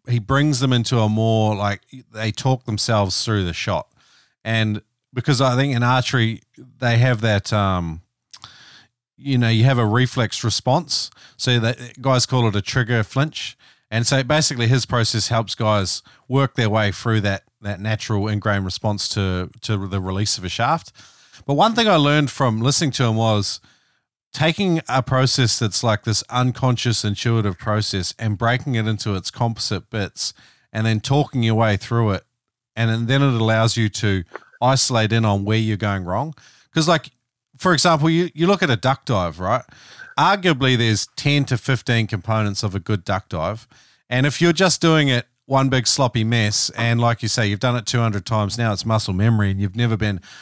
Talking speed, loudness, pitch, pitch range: 185 wpm, -19 LUFS, 115 Hz, 105-130 Hz